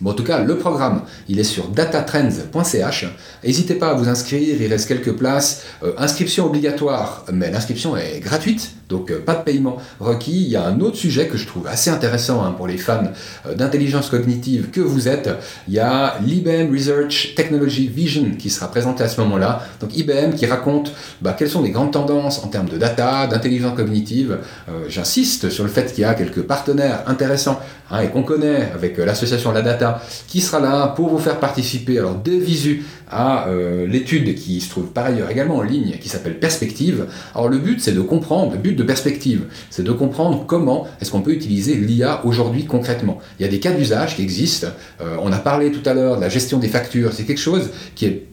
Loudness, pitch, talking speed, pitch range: -18 LUFS, 130 Hz, 215 wpm, 115-150 Hz